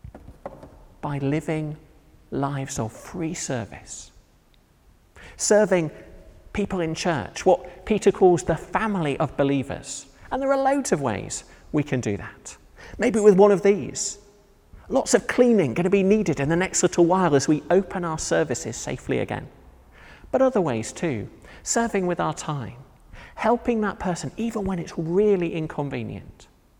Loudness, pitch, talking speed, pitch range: -23 LUFS, 170 Hz, 150 wpm, 140-200 Hz